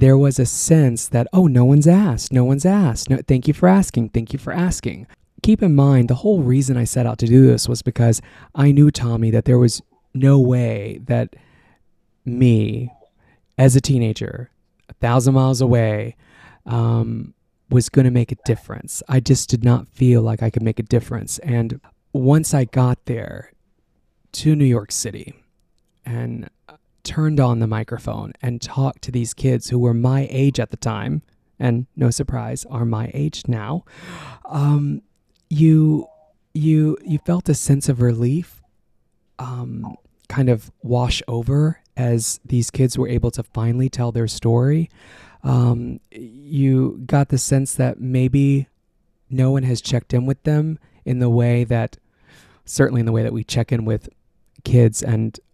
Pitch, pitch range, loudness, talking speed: 125 Hz, 120-140 Hz, -18 LUFS, 170 wpm